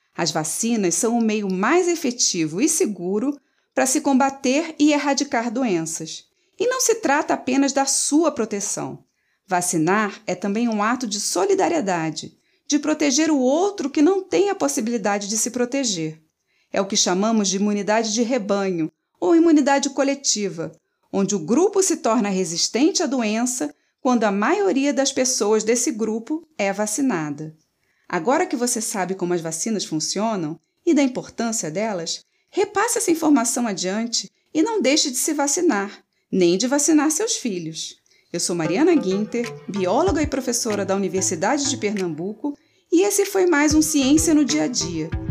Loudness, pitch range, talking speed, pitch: -21 LUFS, 195-300 Hz, 155 wpm, 245 Hz